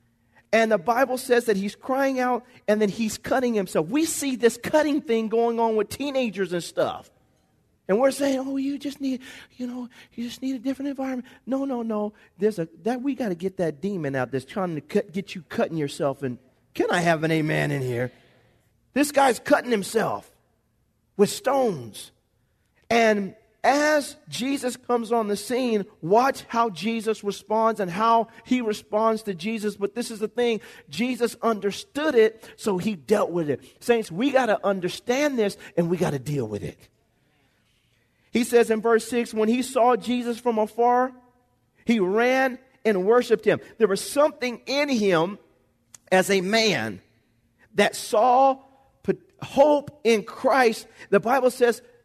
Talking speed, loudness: 170 wpm, -24 LUFS